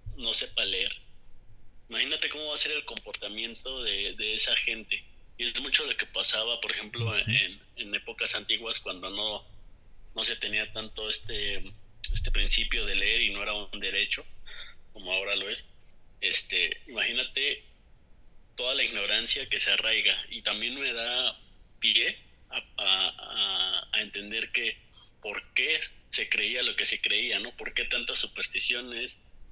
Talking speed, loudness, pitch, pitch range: 155 wpm, -28 LUFS, 110 Hz, 105-125 Hz